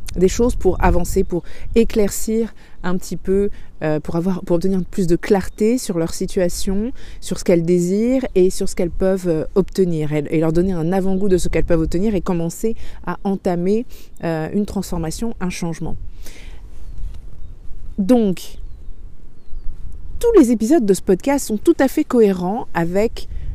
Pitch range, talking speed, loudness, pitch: 175-210 Hz, 160 wpm, -19 LUFS, 190 Hz